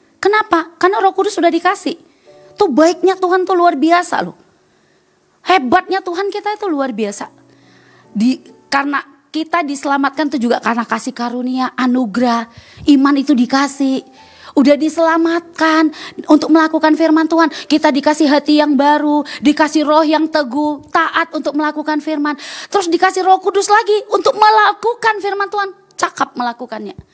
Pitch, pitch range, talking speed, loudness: 310 Hz, 280-360 Hz, 135 wpm, -14 LUFS